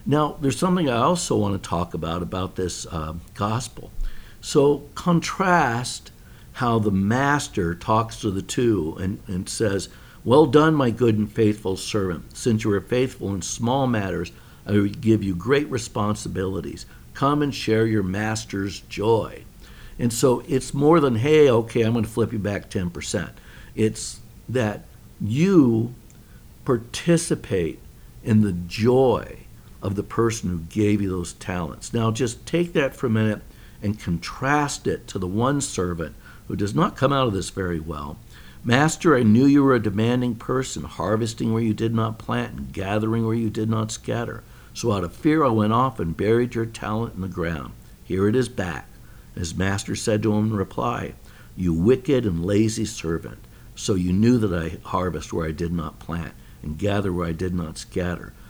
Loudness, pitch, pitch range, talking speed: -23 LUFS, 110 Hz, 95-120 Hz, 175 wpm